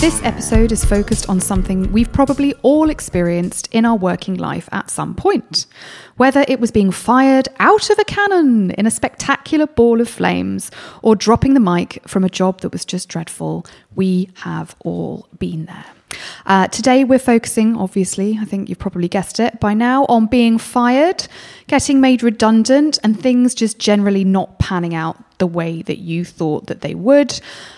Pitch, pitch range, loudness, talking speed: 220 Hz, 185-255 Hz, -15 LUFS, 175 wpm